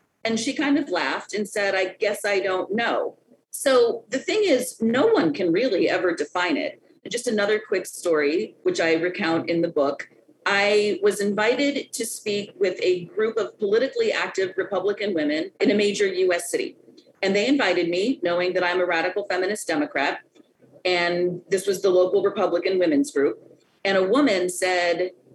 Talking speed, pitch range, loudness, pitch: 175 wpm, 180-260 Hz, -23 LUFS, 200 Hz